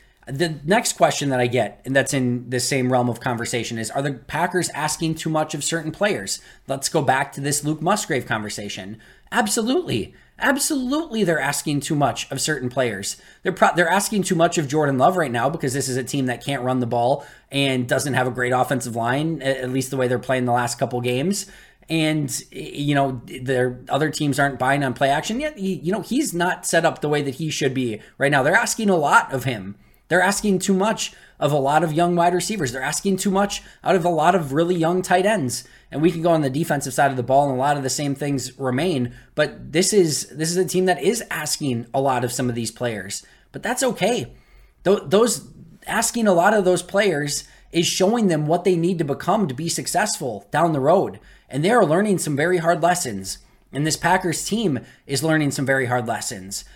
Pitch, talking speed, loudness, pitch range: 145 Hz, 225 wpm, -21 LUFS, 130-180 Hz